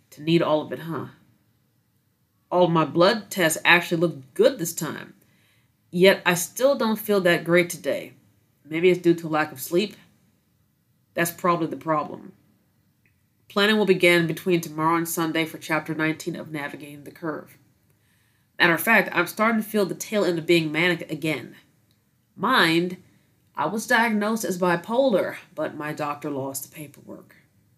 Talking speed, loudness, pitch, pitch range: 165 wpm, -23 LUFS, 170 Hz, 155-185 Hz